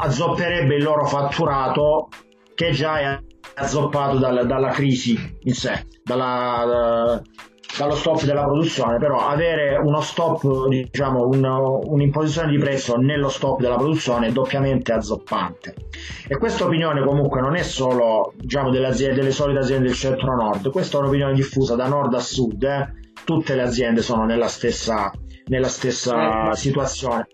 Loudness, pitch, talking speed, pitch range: -20 LUFS, 135 Hz, 145 wpm, 125-145 Hz